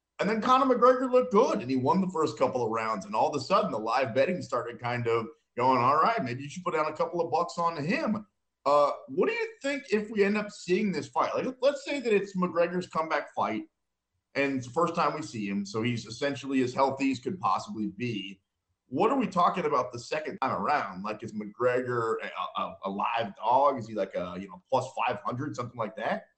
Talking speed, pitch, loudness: 240 wpm, 150 Hz, -29 LUFS